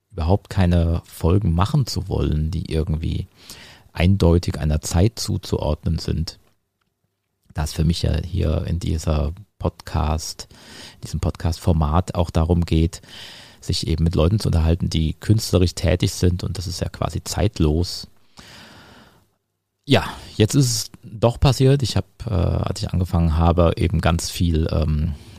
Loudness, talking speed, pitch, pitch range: -21 LUFS, 145 wpm, 90 Hz, 80-100 Hz